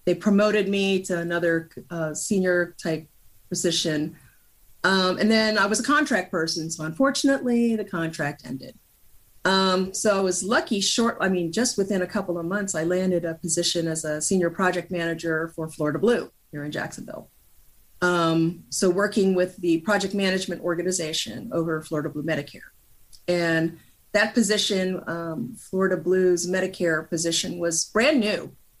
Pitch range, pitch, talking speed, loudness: 160-195 Hz, 175 Hz, 155 wpm, -24 LUFS